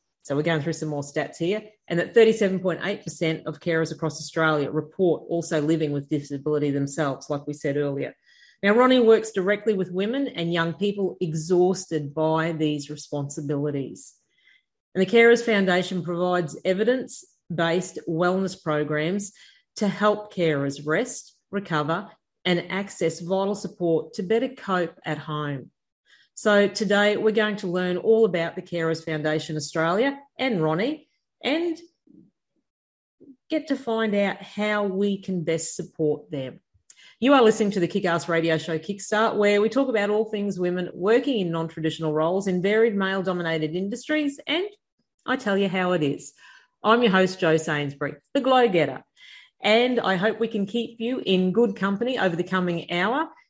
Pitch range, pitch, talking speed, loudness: 160-220 Hz, 185 Hz, 155 wpm, -24 LUFS